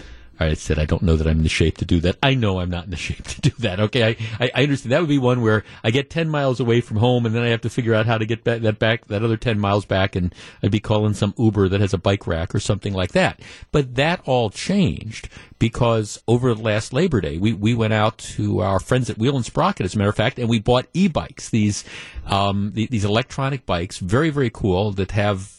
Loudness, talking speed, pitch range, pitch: -20 LUFS, 265 wpm, 100-120 Hz, 110 Hz